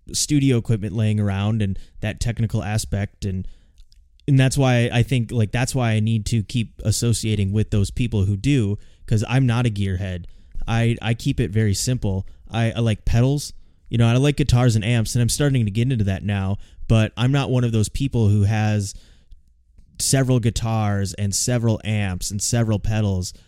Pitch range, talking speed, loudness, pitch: 100-120 Hz, 190 wpm, -21 LUFS, 110 Hz